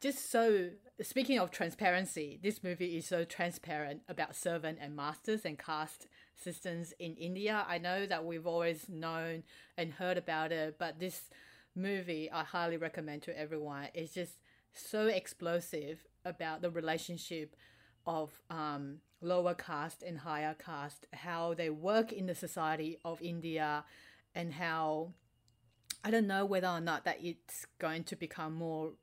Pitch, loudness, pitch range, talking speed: 165 Hz, -38 LUFS, 155-180 Hz, 150 wpm